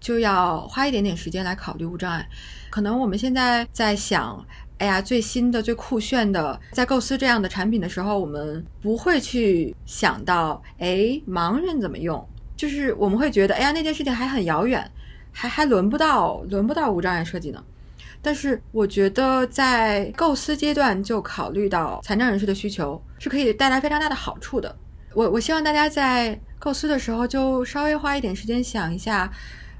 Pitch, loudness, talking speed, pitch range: 230 Hz, -22 LUFS, 285 characters per minute, 200-270 Hz